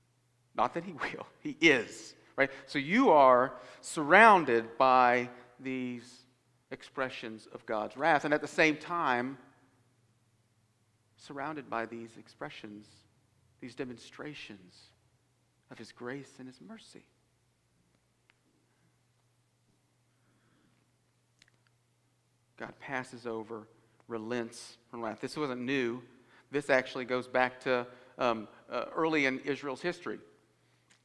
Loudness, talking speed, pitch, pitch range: -29 LUFS, 105 wpm, 125 Hz, 115-130 Hz